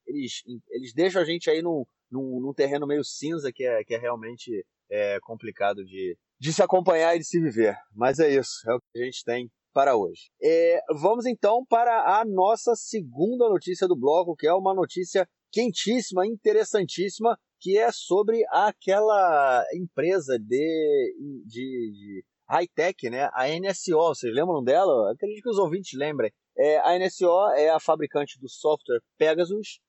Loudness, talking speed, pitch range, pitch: -24 LUFS, 170 wpm, 145-235 Hz, 185 Hz